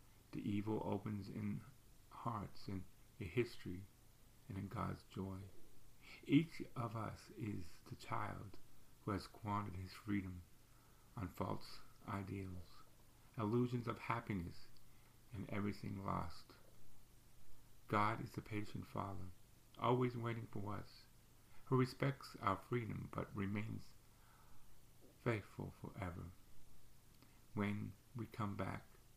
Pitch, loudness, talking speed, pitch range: 110 Hz, -45 LUFS, 110 wpm, 100-120 Hz